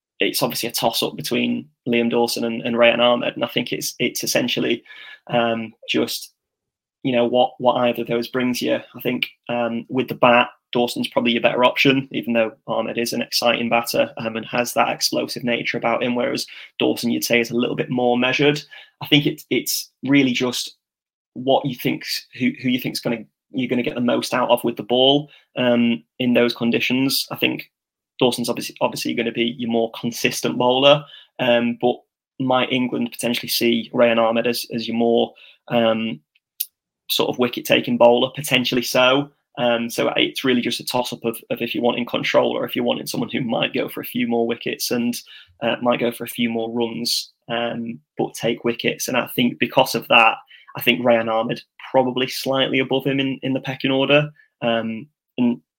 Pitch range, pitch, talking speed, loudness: 115-130 Hz, 120 Hz, 200 wpm, -20 LUFS